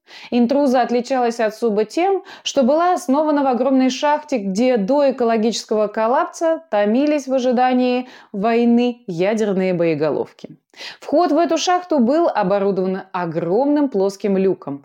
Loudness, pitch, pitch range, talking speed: -18 LUFS, 250 Hz, 210-290 Hz, 120 wpm